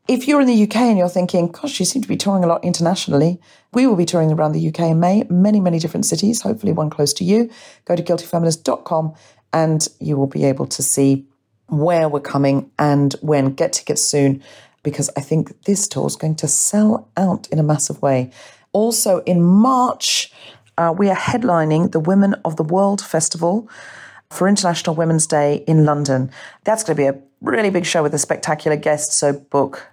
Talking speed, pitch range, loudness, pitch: 200 wpm, 150-195 Hz, -17 LUFS, 165 Hz